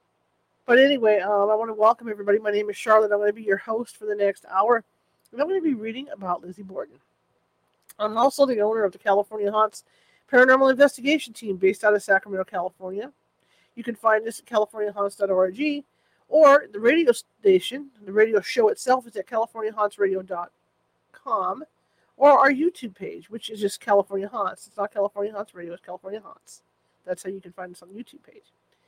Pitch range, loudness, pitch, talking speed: 200-255 Hz, -22 LUFS, 215 Hz, 190 wpm